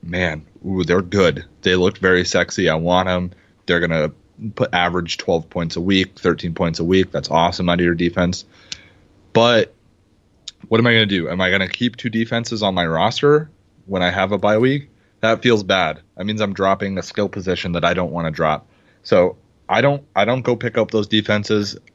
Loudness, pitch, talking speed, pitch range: -18 LUFS, 95 Hz, 205 wpm, 90-110 Hz